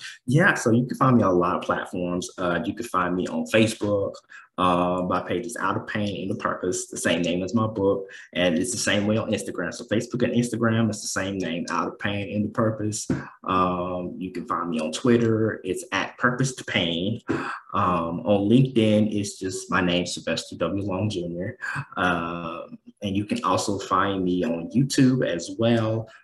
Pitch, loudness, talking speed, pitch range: 100 Hz, -24 LUFS, 205 wpm, 90-110 Hz